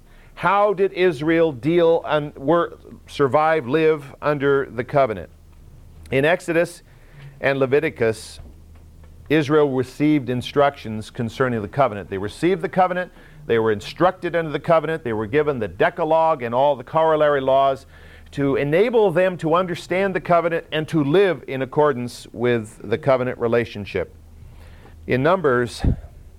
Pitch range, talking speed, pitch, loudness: 110-160 Hz, 130 wpm, 140 Hz, -20 LUFS